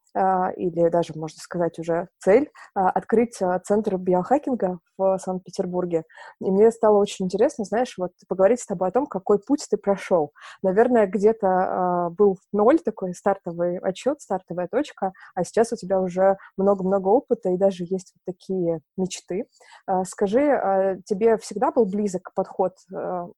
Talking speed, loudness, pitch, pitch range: 145 wpm, -23 LUFS, 190 Hz, 180-215 Hz